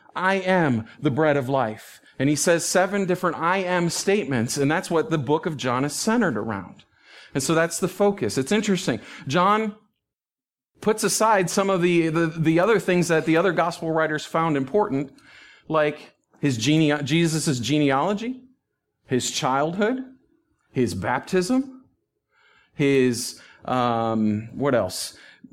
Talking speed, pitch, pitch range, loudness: 145 wpm, 165 Hz, 145-195 Hz, -22 LUFS